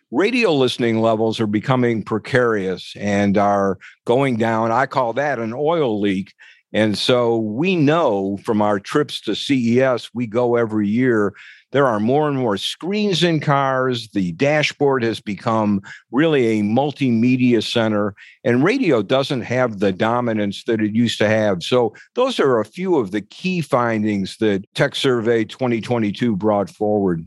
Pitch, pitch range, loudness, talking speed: 115 Hz, 105-130 Hz, -19 LUFS, 155 wpm